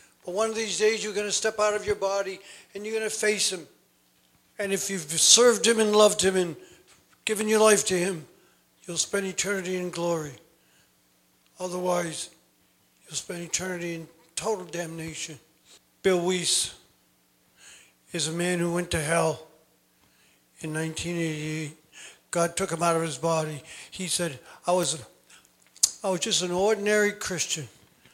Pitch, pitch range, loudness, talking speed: 175 Hz, 155-200 Hz, -26 LUFS, 155 wpm